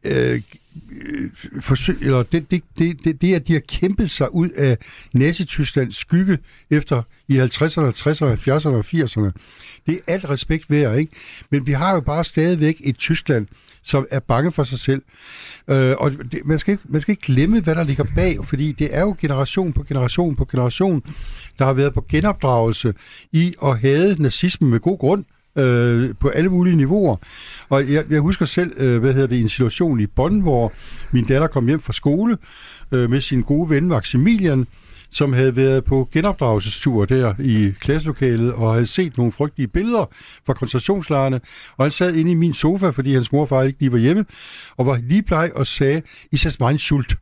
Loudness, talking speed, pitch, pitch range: -19 LUFS, 195 wpm, 140 Hz, 130-165 Hz